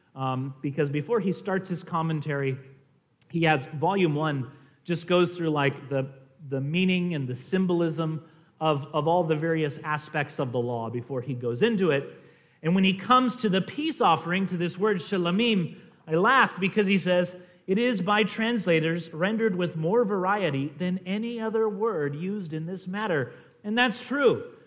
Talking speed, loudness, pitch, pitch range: 175 wpm, -26 LUFS, 175 Hz, 150-200 Hz